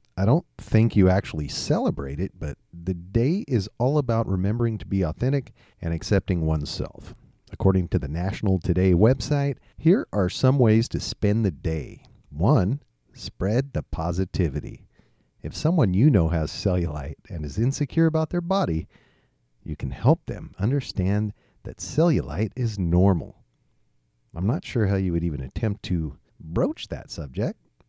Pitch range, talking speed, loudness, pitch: 85-115 Hz, 155 wpm, -24 LUFS, 95 Hz